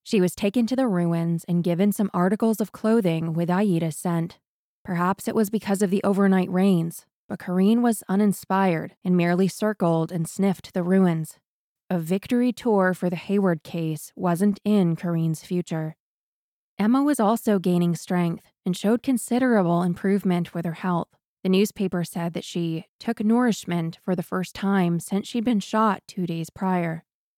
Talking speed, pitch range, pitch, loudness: 165 wpm, 170-205 Hz, 185 Hz, -24 LUFS